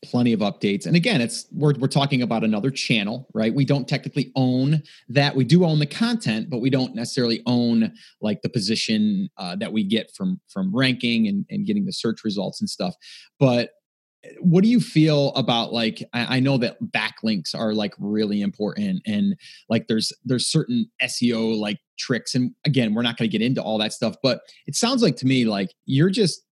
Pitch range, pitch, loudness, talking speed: 115-185 Hz, 135 Hz, -22 LUFS, 205 wpm